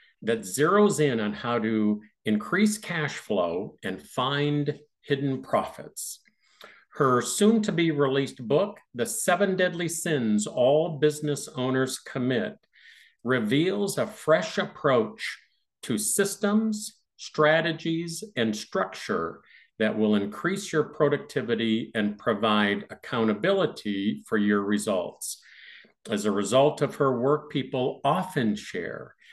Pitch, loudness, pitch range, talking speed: 145 Hz, -26 LUFS, 115-180 Hz, 115 wpm